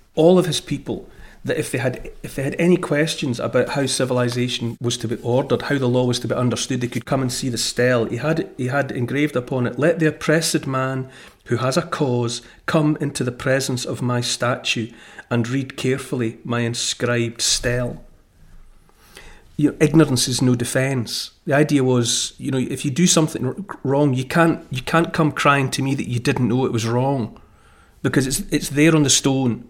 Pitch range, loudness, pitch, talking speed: 125-145 Hz, -20 LUFS, 130 Hz, 200 wpm